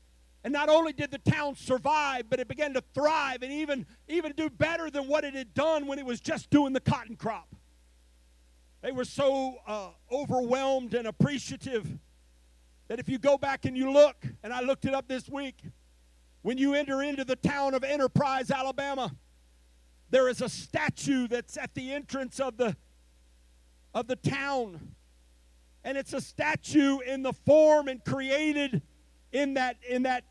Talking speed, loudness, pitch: 170 wpm, -29 LUFS, 260 Hz